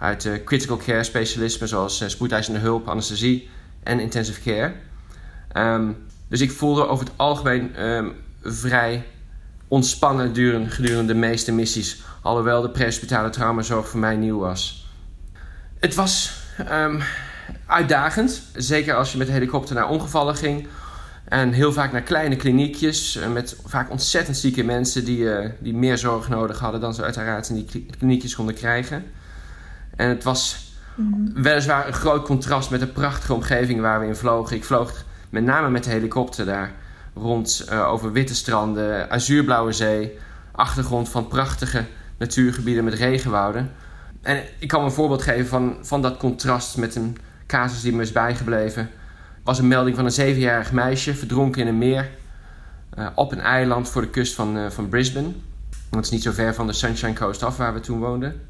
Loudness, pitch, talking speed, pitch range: -22 LUFS, 120 Hz, 170 wpm, 110-130 Hz